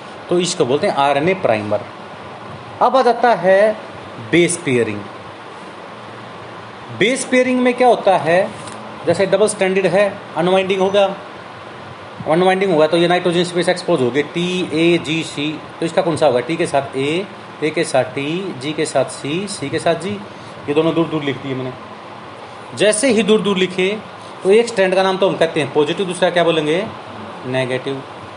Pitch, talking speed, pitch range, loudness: 170 Hz, 180 wpm, 140-190 Hz, -16 LUFS